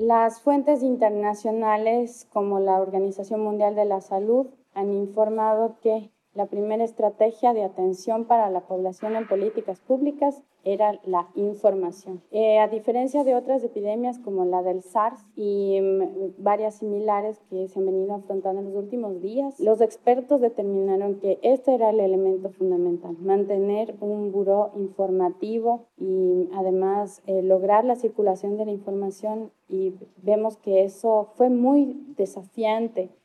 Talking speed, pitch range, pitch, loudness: 145 wpm, 195-225 Hz, 210 Hz, -24 LUFS